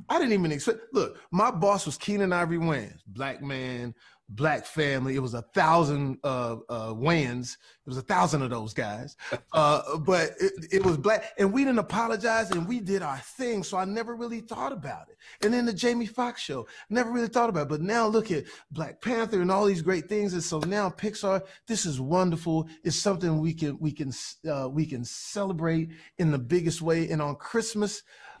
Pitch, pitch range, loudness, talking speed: 175 Hz, 150-215 Hz, -28 LUFS, 205 wpm